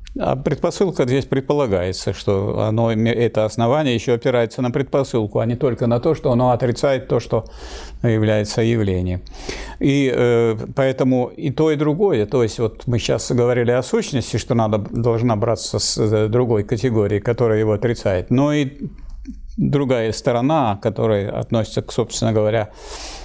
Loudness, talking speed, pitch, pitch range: -19 LUFS, 150 wpm, 120 Hz, 110-135 Hz